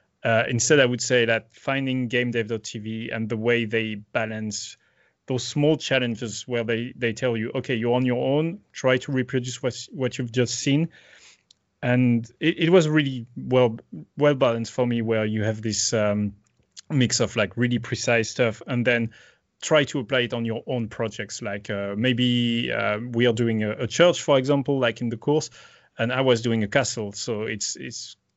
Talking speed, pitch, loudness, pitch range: 190 wpm, 120 Hz, -24 LUFS, 115-130 Hz